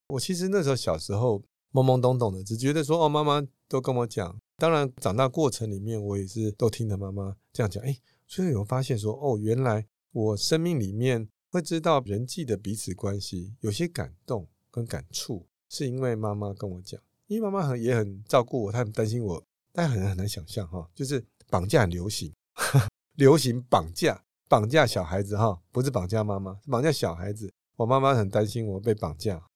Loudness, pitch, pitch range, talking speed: -27 LUFS, 115 Hz, 100-135 Hz, 305 characters per minute